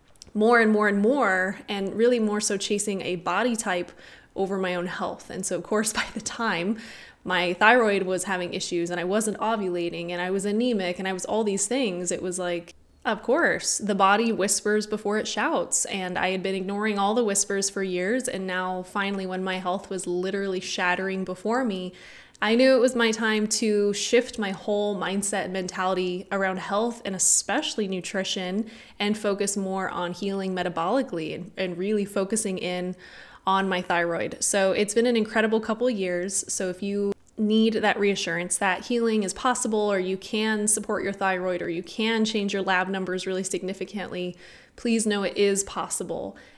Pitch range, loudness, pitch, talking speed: 185-215 Hz, -25 LUFS, 195 Hz, 185 wpm